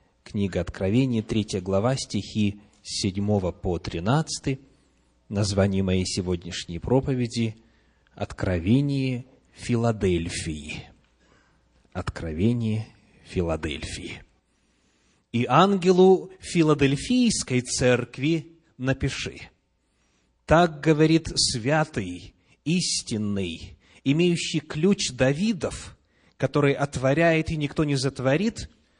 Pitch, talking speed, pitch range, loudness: 115 Hz, 70 wpm, 95-140 Hz, -24 LUFS